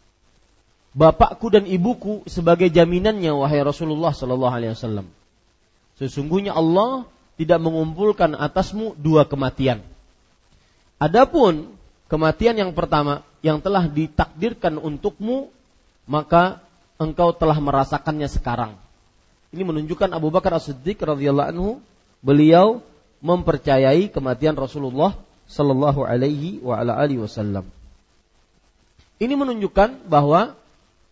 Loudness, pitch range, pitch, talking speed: -20 LUFS, 130-180 Hz, 155 Hz, 90 wpm